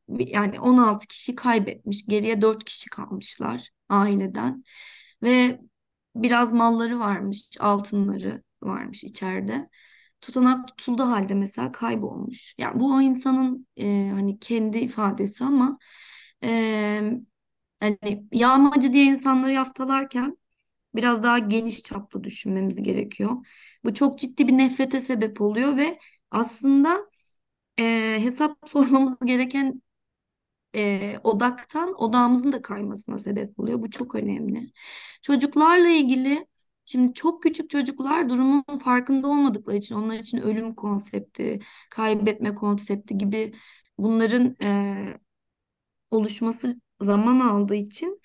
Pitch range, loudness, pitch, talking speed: 210-265 Hz, -23 LUFS, 235 Hz, 110 wpm